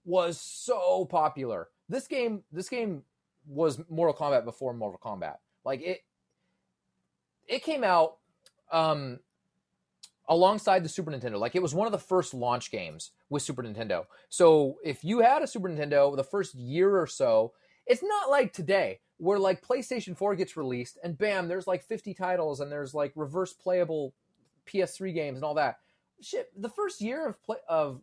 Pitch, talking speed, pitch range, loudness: 180 Hz, 170 wpm, 150-205 Hz, -29 LUFS